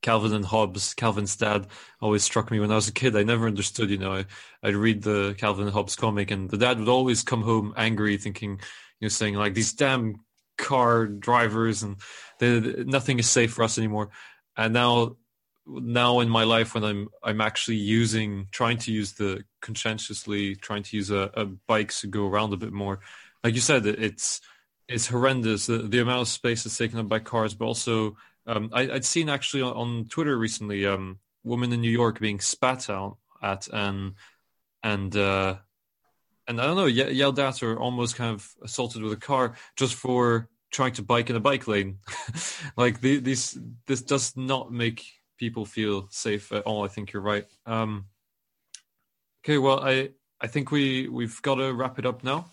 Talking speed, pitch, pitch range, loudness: 200 wpm, 115 Hz, 105-125 Hz, -26 LUFS